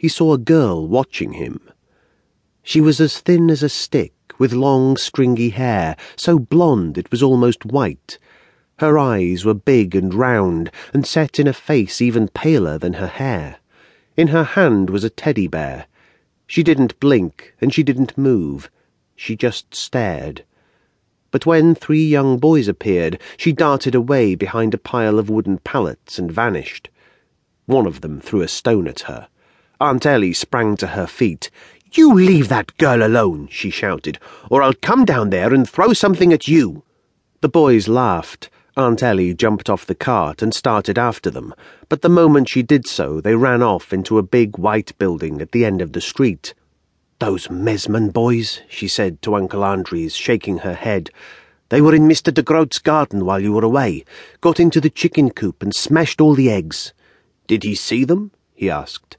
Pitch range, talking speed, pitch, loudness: 105-155 Hz, 175 wpm, 125 Hz, -16 LUFS